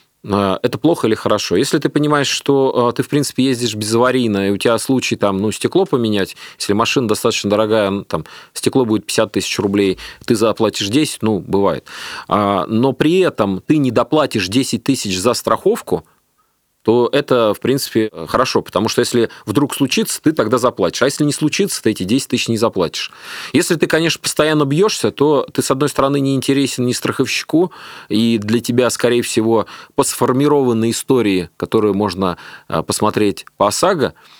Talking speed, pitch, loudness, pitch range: 170 wpm, 120 Hz, -16 LUFS, 105-140 Hz